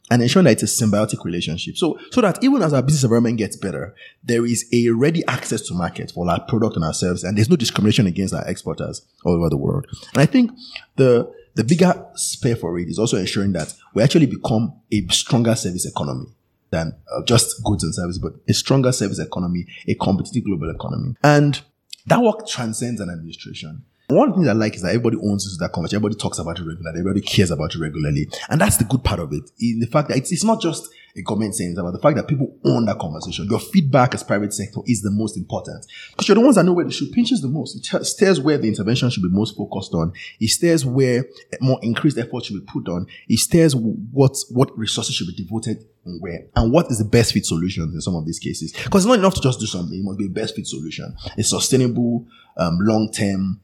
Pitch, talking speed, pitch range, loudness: 110 Hz, 240 wpm, 100-135 Hz, -19 LUFS